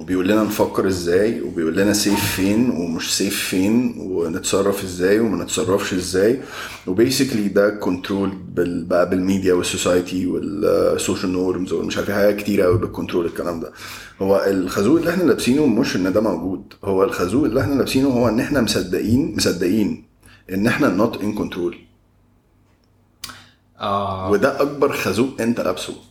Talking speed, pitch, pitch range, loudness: 140 wpm, 100 Hz, 95-110 Hz, -19 LUFS